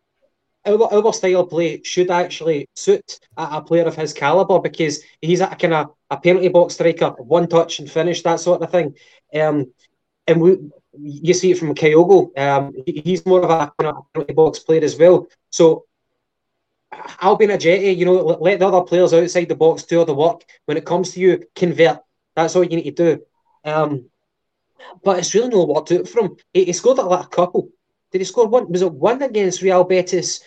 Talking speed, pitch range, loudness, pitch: 210 wpm, 160-185 Hz, -17 LUFS, 175 Hz